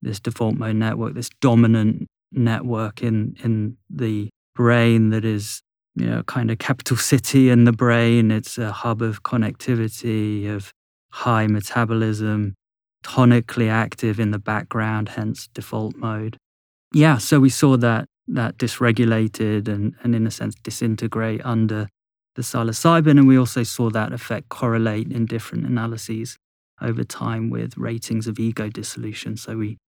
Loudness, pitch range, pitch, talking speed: -20 LUFS, 110-120 Hz, 115 Hz, 145 wpm